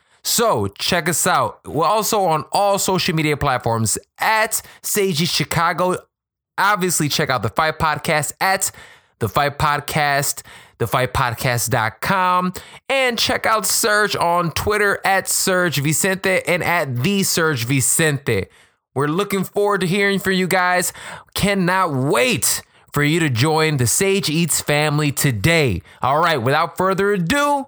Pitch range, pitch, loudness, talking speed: 145-195 Hz, 170 Hz, -18 LUFS, 140 wpm